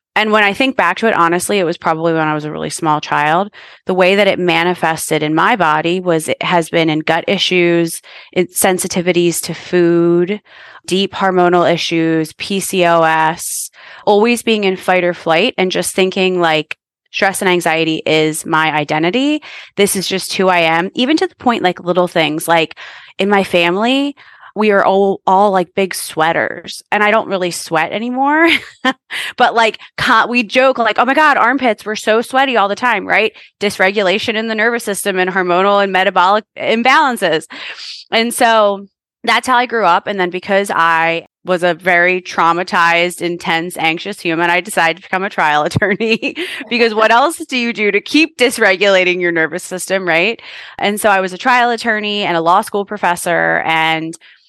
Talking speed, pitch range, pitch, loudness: 180 wpm, 170-215 Hz, 185 Hz, -13 LUFS